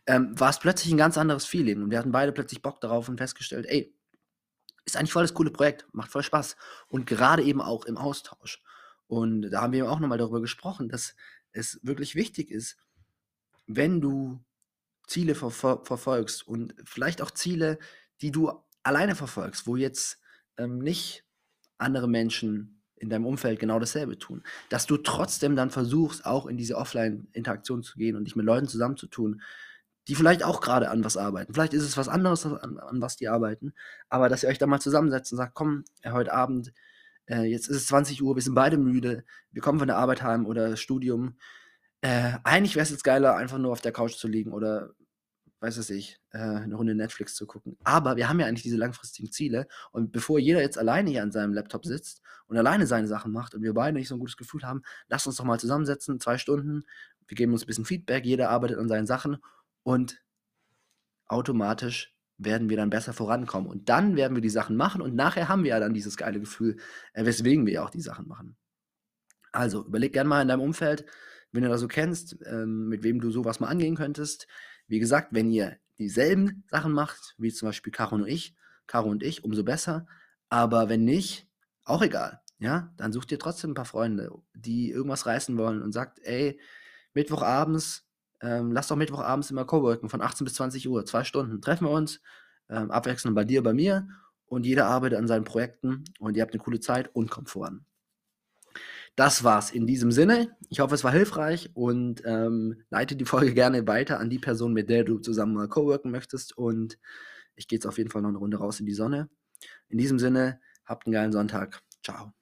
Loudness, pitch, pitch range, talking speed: -27 LUFS, 125 Hz, 115-145 Hz, 205 wpm